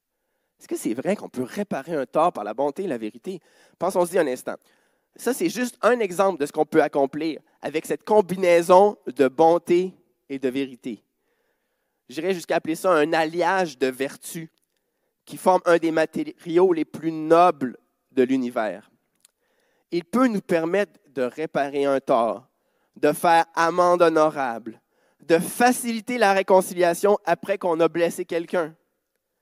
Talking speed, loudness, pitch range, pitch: 155 wpm, -22 LUFS, 155-200 Hz, 170 Hz